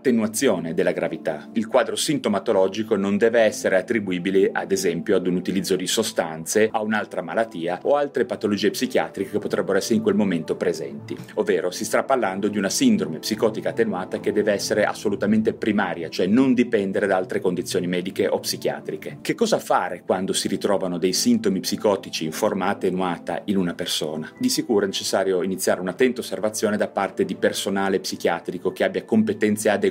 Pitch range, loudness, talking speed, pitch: 95-130 Hz, -22 LUFS, 170 wpm, 105 Hz